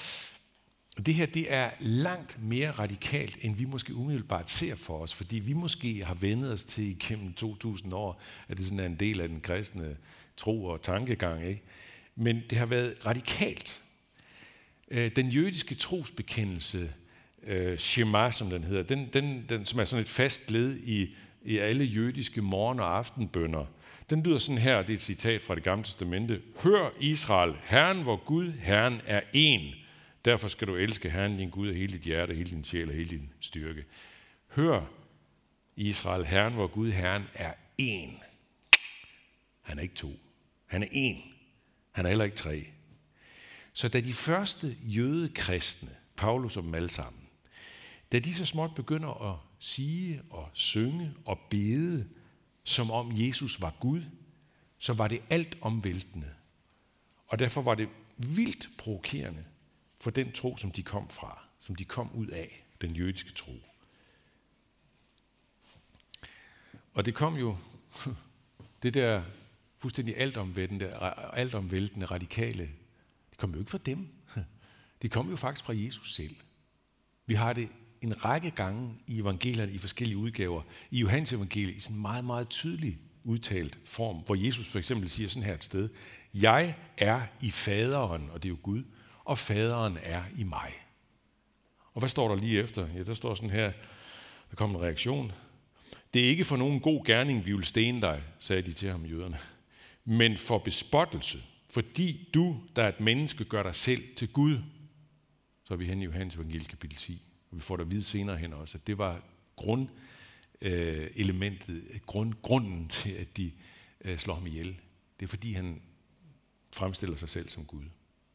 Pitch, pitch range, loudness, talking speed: 110 Hz, 90-125 Hz, -31 LUFS, 165 wpm